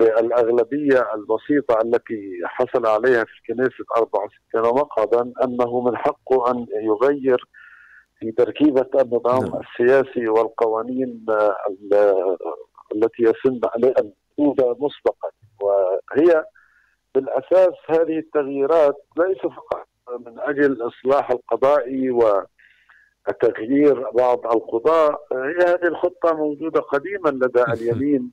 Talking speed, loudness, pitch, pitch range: 90 wpm, -20 LUFS, 130 Hz, 115-145 Hz